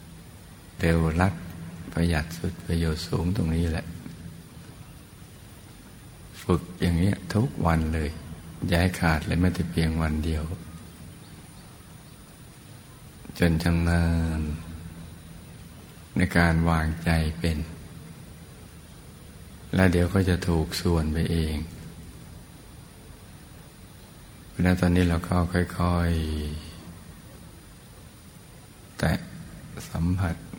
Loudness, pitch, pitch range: -26 LUFS, 85 Hz, 80-85 Hz